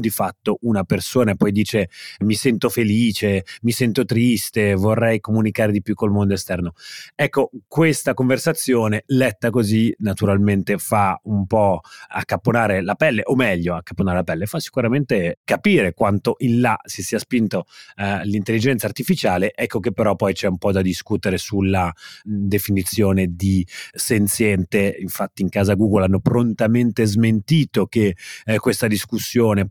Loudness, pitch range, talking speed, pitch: -19 LUFS, 100-120 Hz, 145 wpm, 105 Hz